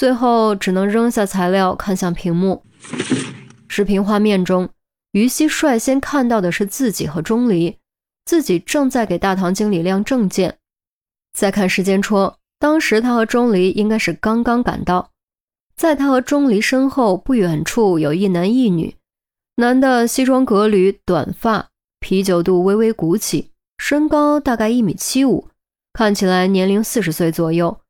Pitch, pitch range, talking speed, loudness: 210 Hz, 185-245 Hz, 230 characters per minute, -16 LUFS